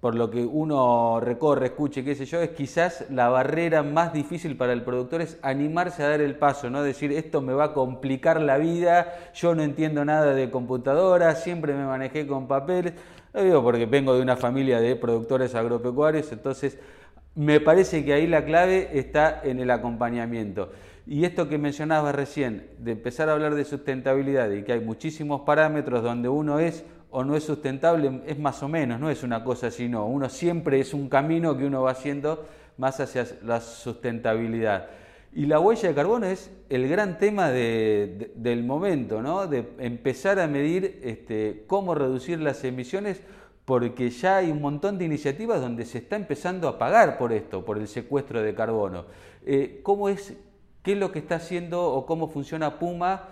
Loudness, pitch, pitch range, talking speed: -25 LUFS, 145 Hz, 125-165 Hz, 185 wpm